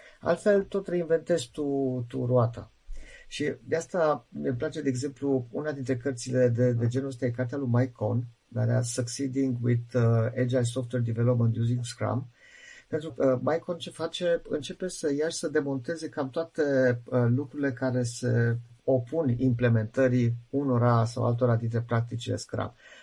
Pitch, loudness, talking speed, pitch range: 130 Hz, -28 LUFS, 160 wpm, 120-150 Hz